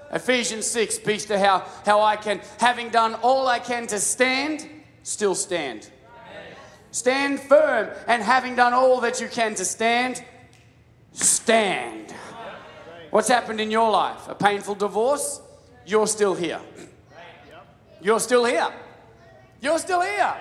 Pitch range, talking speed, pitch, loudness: 205-255 Hz, 135 wpm, 225 Hz, -22 LUFS